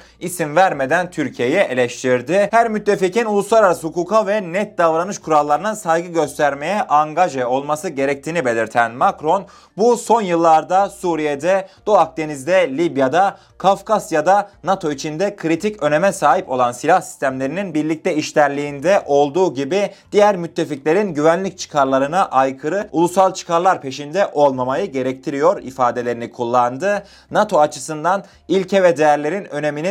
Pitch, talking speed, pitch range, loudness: 165 Hz, 115 wpm, 145-195 Hz, -17 LUFS